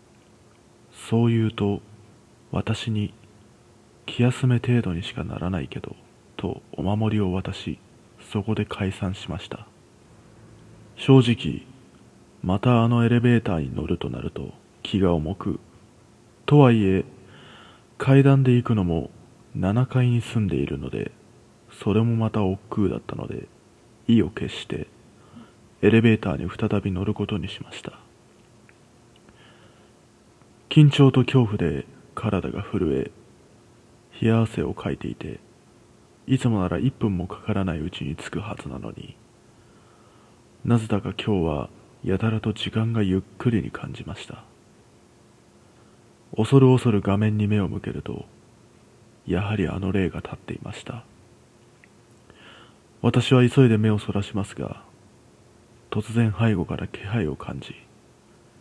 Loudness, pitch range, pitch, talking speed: -23 LUFS, 95-120 Hz, 110 Hz, 240 characters per minute